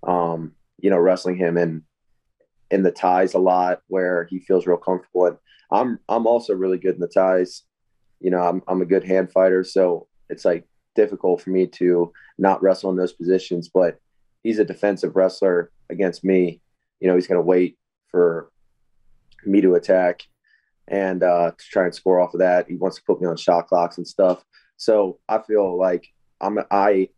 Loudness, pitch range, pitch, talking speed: -20 LUFS, 90-95 Hz, 90 Hz, 190 wpm